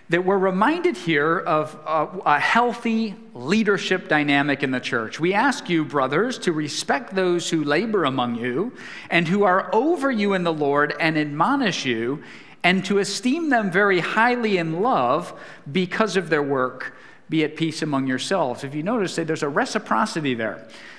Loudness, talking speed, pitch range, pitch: -21 LUFS, 165 wpm, 150-215 Hz, 170 Hz